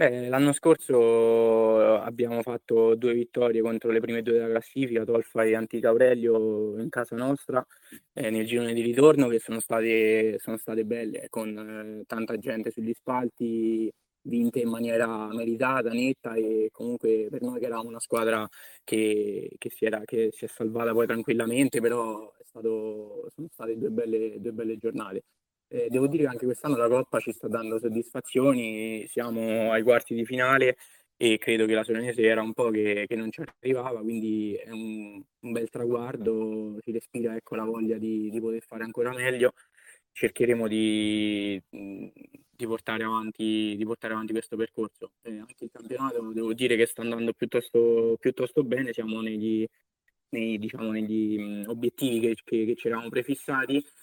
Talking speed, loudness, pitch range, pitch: 165 wpm, -27 LUFS, 110-120 Hz, 115 Hz